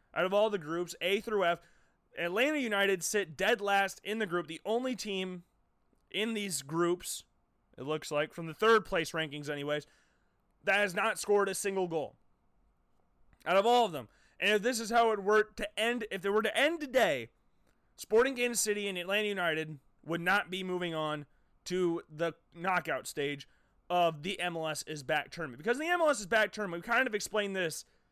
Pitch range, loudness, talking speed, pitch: 165-215 Hz, -32 LUFS, 190 wpm, 190 Hz